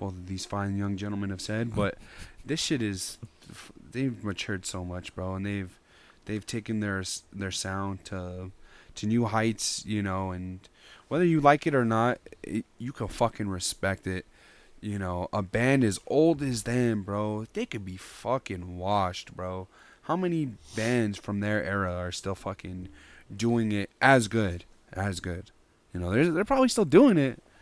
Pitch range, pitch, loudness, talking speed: 95-115 Hz, 100 Hz, -28 LUFS, 170 wpm